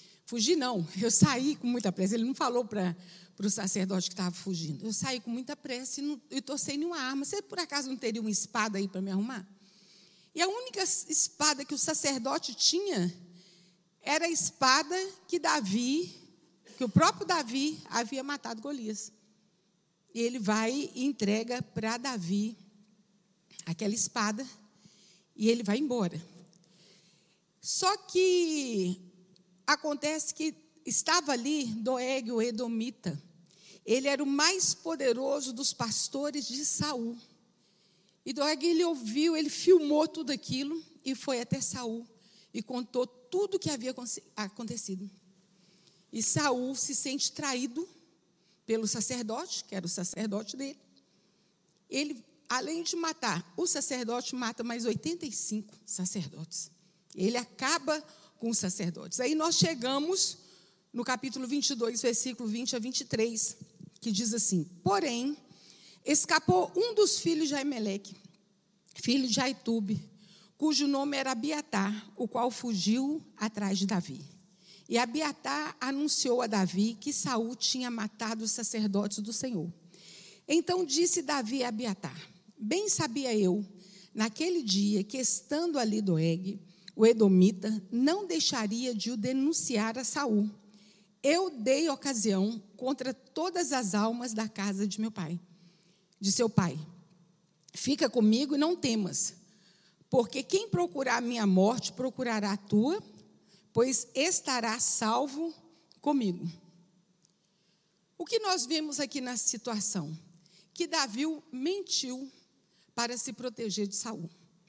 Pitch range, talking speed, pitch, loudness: 195-280 Hz, 130 wpm, 230 Hz, -30 LUFS